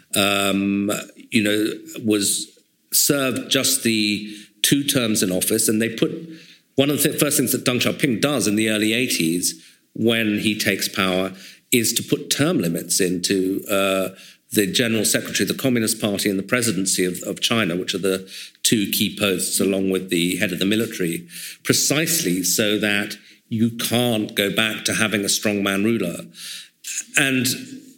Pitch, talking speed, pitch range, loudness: 105 Hz, 165 wpm, 95-115 Hz, -20 LUFS